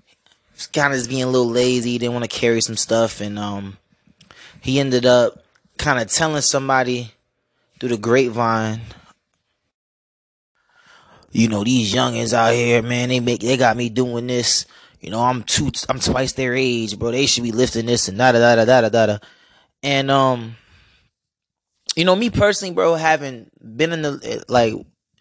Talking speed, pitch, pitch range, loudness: 175 wpm, 120 Hz, 115-130 Hz, -18 LUFS